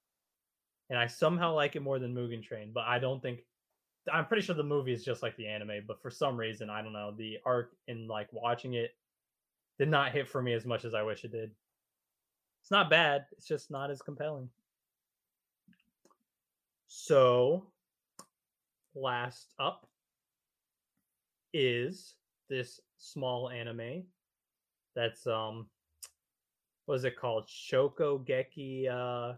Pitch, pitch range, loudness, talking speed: 125 Hz, 115-145 Hz, -33 LUFS, 145 wpm